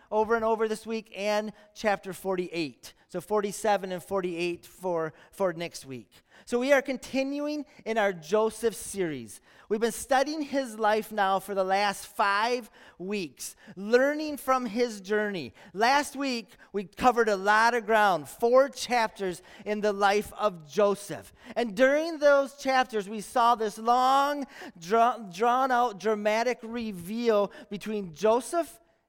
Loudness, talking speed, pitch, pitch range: -27 LUFS, 140 wpm, 215 Hz, 195-245 Hz